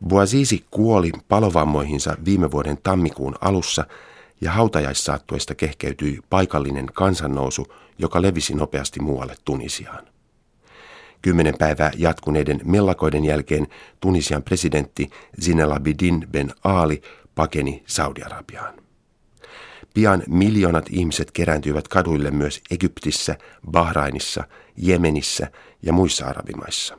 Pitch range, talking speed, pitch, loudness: 75-90 Hz, 95 wpm, 80 Hz, -21 LUFS